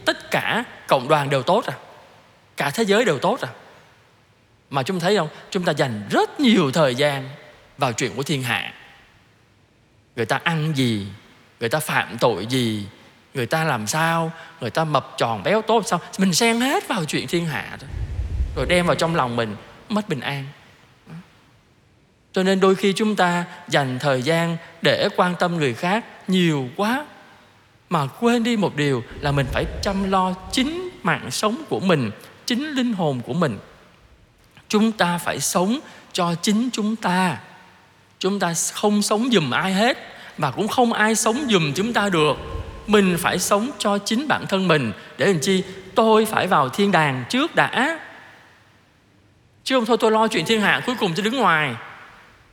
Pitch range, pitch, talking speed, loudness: 130-210 Hz, 170 Hz, 180 wpm, -21 LUFS